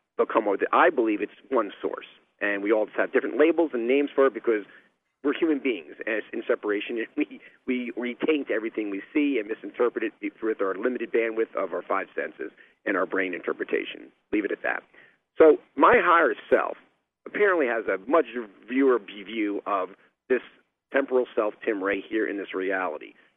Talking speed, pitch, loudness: 180 wpm, 135 Hz, -26 LUFS